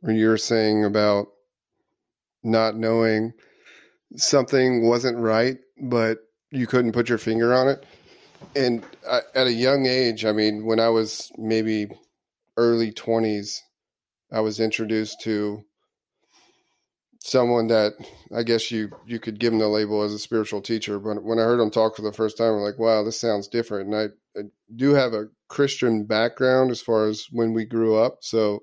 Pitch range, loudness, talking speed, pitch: 110-120 Hz, -22 LUFS, 170 wpm, 110 Hz